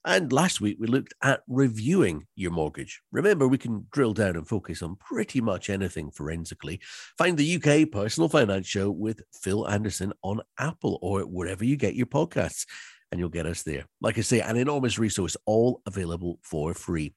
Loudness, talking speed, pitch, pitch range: -27 LUFS, 185 wpm, 105 Hz, 85-120 Hz